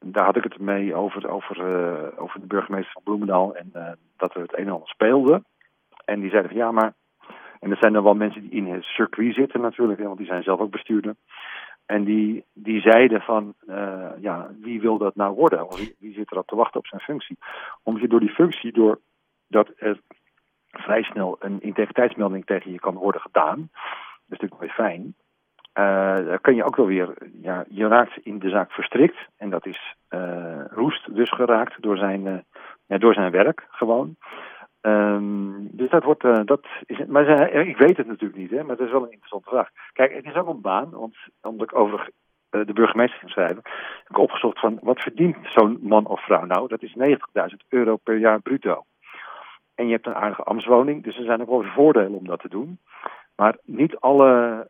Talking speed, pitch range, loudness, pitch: 210 wpm, 100-115 Hz, -21 LUFS, 110 Hz